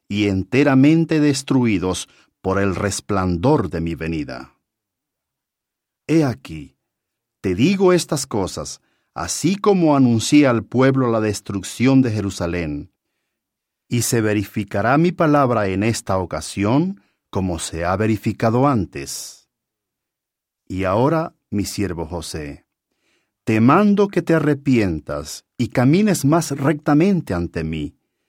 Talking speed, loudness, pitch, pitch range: 110 wpm, -19 LUFS, 115 Hz, 95-145 Hz